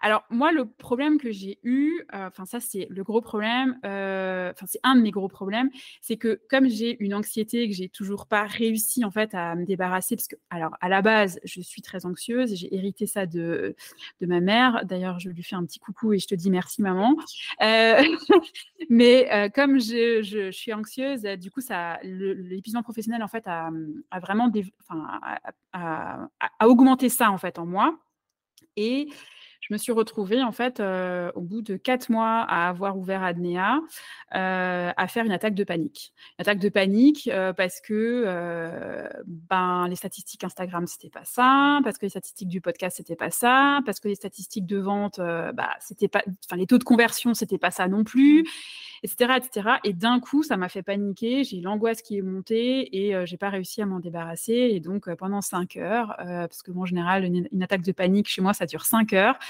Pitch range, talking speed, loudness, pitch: 185-235 Hz, 215 wpm, -24 LUFS, 205 Hz